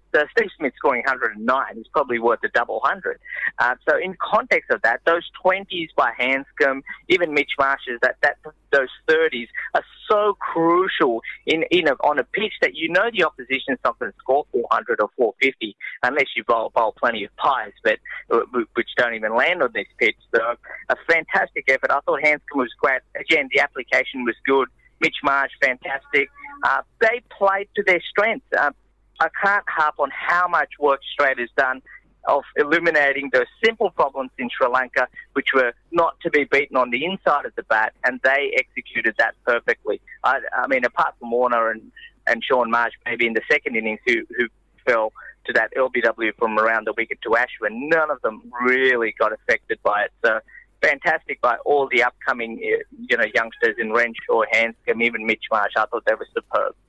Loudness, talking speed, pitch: -20 LUFS, 190 wpm, 160 Hz